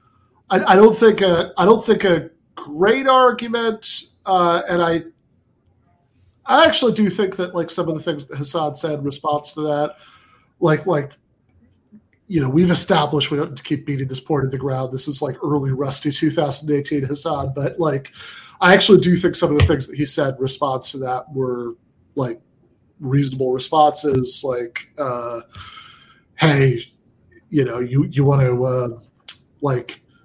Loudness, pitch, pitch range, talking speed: -18 LUFS, 150 Hz, 135-175 Hz, 170 wpm